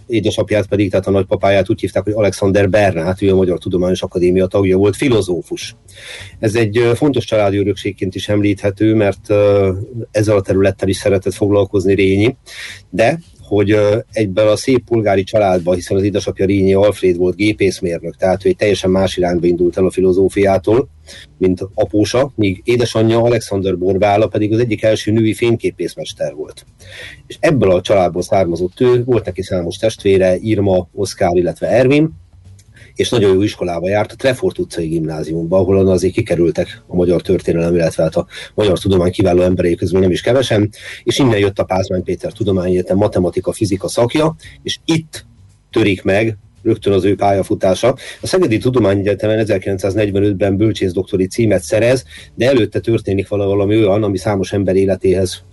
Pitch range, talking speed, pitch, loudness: 95-110 Hz, 160 wpm, 100 Hz, -15 LUFS